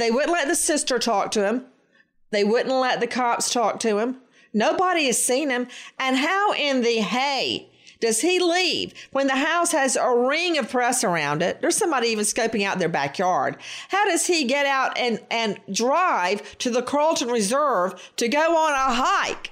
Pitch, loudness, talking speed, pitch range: 255 Hz, -22 LUFS, 190 wpm, 230-305 Hz